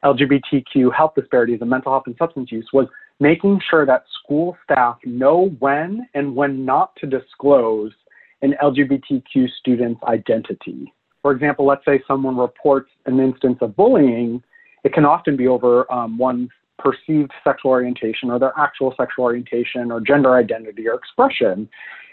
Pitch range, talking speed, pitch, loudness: 125-145 Hz, 150 wpm, 135 Hz, -18 LUFS